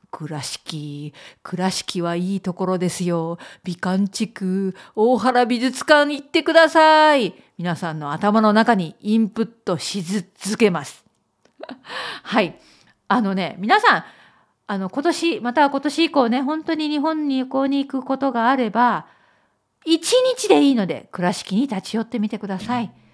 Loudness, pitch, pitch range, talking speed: -20 LUFS, 220 Hz, 185-275 Hz, 270 characters per minute